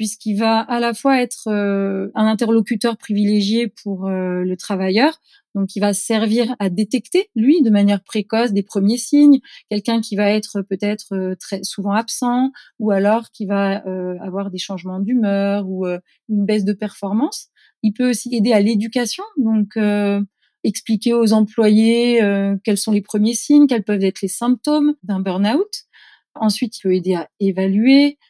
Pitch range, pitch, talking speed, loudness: 200-235 Hz, 215 Hz, 155 wpm, -18 LUFS